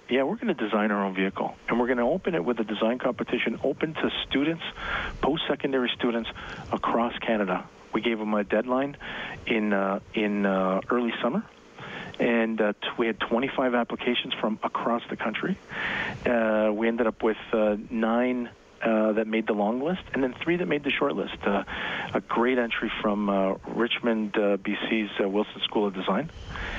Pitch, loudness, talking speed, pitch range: 115 Hz, -27 LUFS, 185 wpm, 105-125 Hz